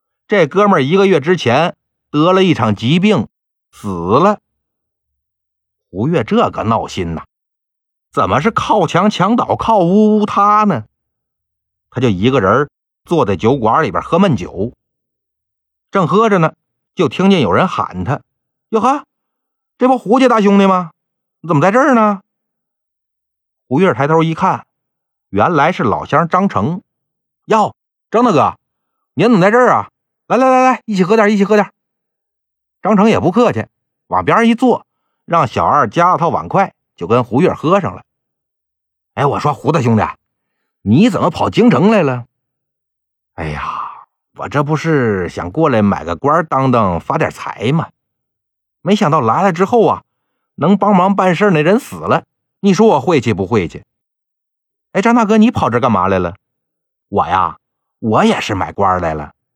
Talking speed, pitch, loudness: 220 characters per minute, 180 Hz, -13 LUFS